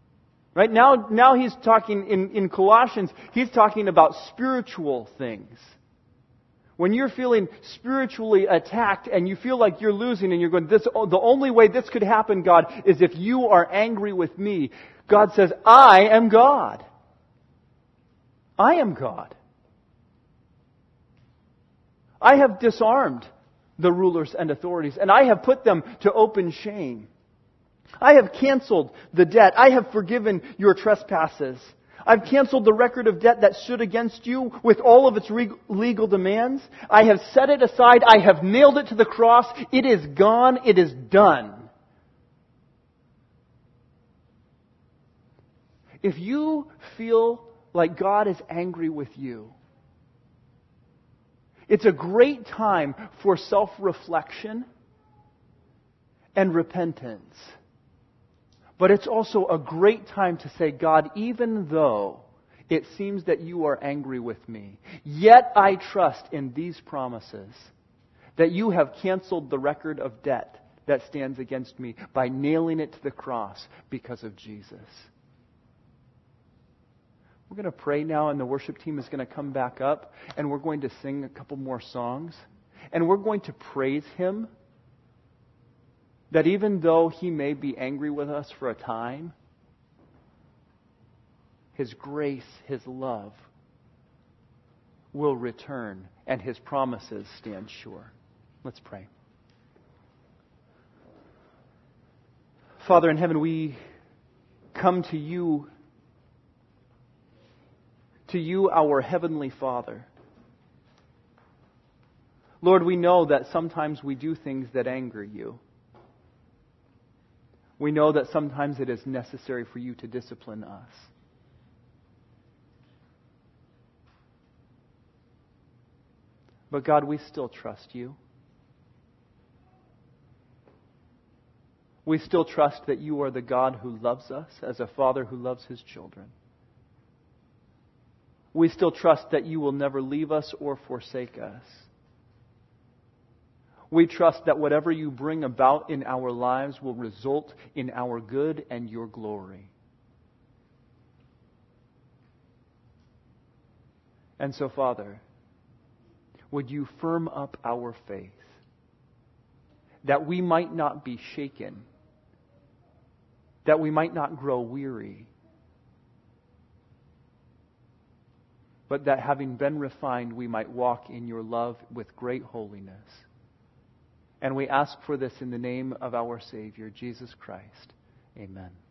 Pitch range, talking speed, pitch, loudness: 120-185 Hz, 125 wpm, 140 Hz, -21 LUFS